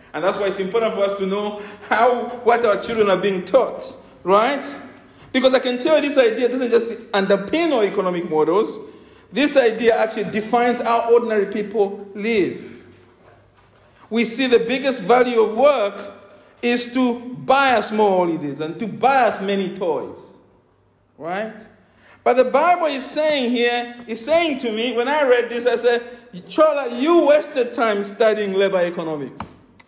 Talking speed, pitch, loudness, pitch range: 165 wpm, 230 Hz, -19 LUFS, 205-250 Hz